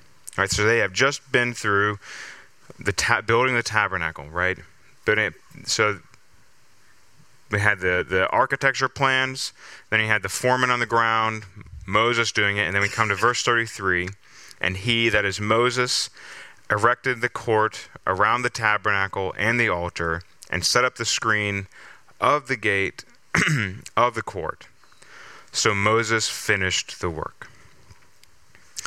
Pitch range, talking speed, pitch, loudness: 100-120 Hz, 150 wpm, 110 Hz, -22 LUFS